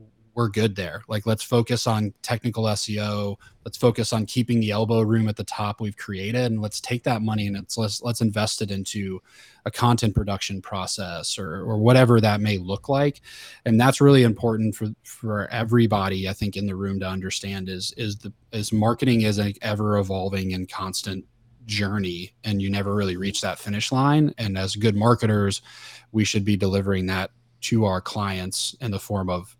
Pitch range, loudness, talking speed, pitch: 100-115 Hz, -23 LUFS, 190 wpm, 105 Hz